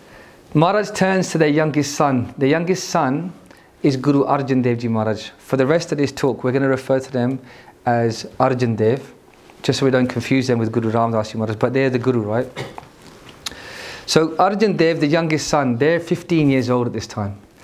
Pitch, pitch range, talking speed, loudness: 135 Hz, 120-155 Hz, 195 wpm, -19 LUFS